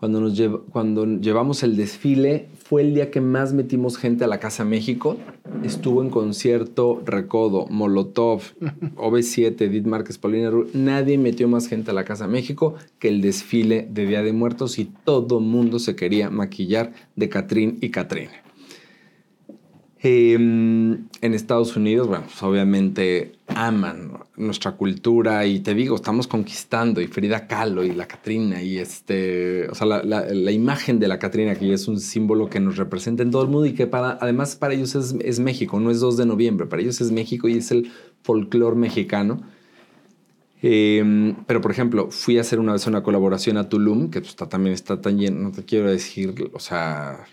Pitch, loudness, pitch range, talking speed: 115 Hz, -21 LUFS, 105-120 Hz, 180 wpm